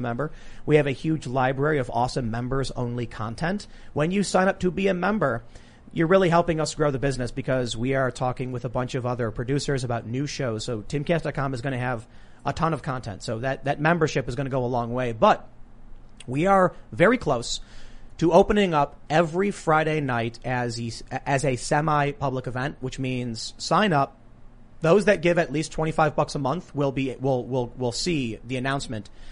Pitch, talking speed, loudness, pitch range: 135 Hz, 200 wpm, -25 LUFS, 125-155 Hz